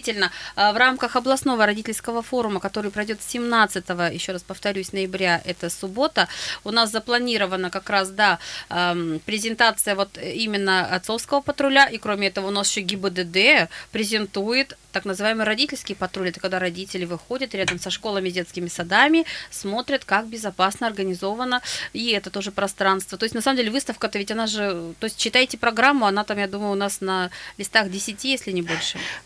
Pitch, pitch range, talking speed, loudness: 205 Hz, 190-230 Hz, 160 wpm, -22 LUFS